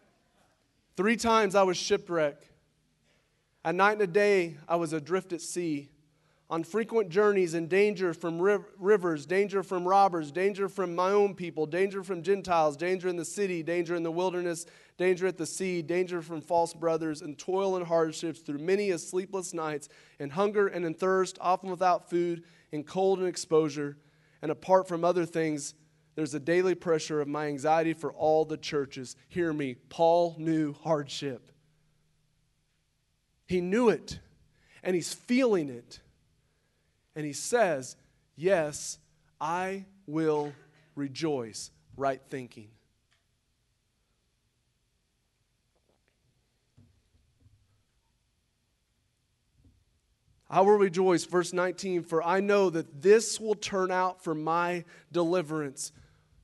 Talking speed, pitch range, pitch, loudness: 130 wpm, 150-185 Hz, 165 Hz, -29 LUFS